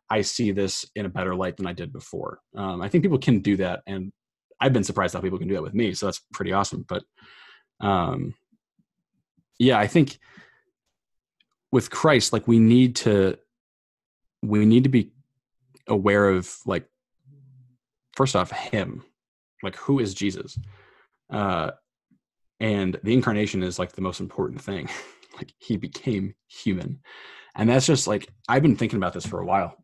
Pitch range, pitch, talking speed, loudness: 100-130 Hz, 110 Hz, 170 wpm, -24 LUFS